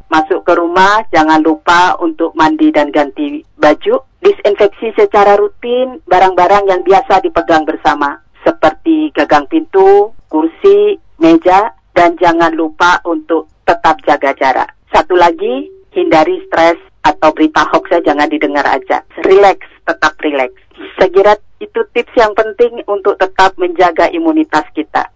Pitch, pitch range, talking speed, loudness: 180 Hz, 160-225 Hz, 125 wpm, -10 LUFS